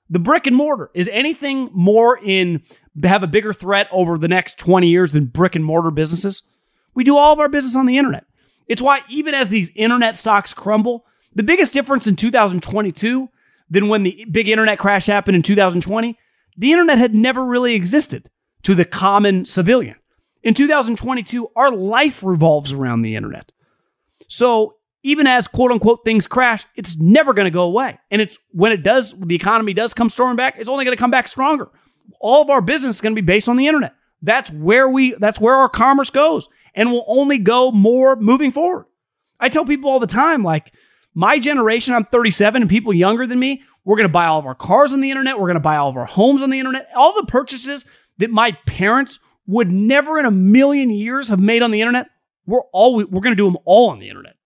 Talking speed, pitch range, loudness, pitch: 215 wpm, 195-265 Hz, -15 LUFS, 230 Hz